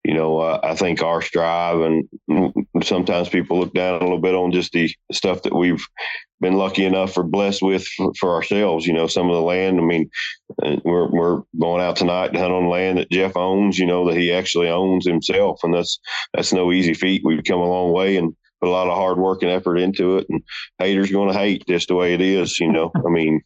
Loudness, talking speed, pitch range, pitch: -19 LUFS, 240 wpm, 85-95 Hz, 90 Hz